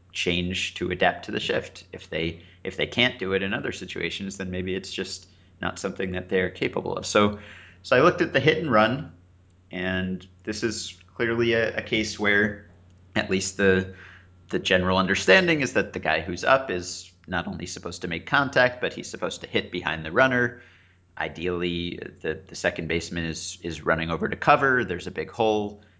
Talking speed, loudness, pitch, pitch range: 195 wpm, -25 LUFS, 95 Hz, 90-105 Hz